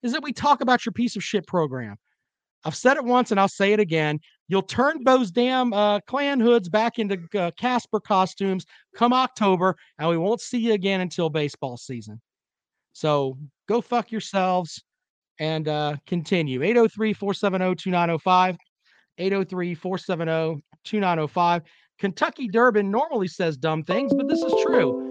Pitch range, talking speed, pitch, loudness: 165-230 Hz, 155 wpm, 190 Hz, -23 LUFS